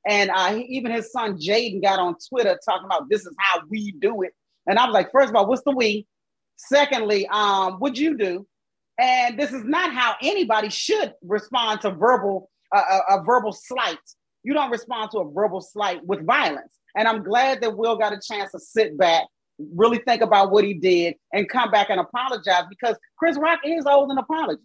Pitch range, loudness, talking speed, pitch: 200-260 Hz, -21 LUFS, 210 wpm, 215 Hz